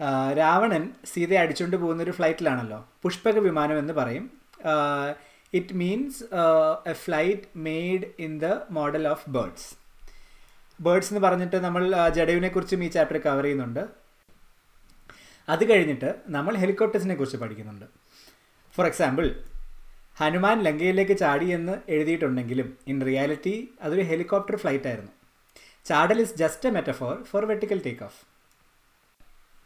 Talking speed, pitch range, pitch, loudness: 115 wpm, 150-195 Hz, 170 Hz, -25 LUFS